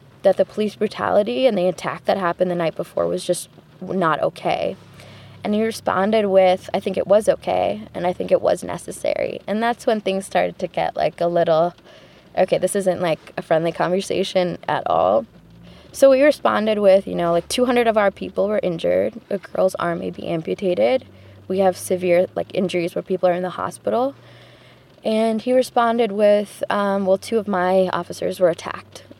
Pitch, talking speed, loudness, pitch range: 190 Hz, 190 wpm, -20 LUFS, 180-215 Hz